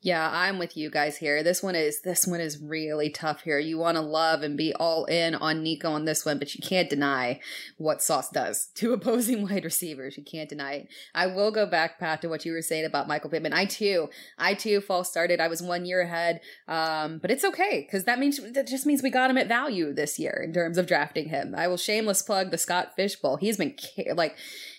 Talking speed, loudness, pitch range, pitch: 240 wpm, -27 LUFS, 155-195 Hz, 170 Hz